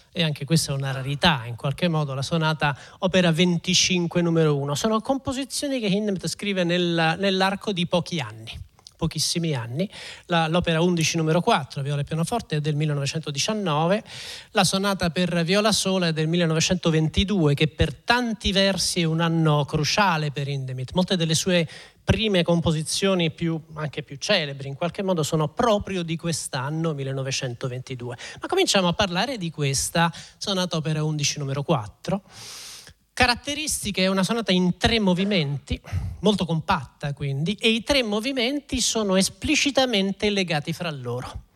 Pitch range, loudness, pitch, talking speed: 150-195 Hz, -23 LUFS, 170 Hz, 150 wpm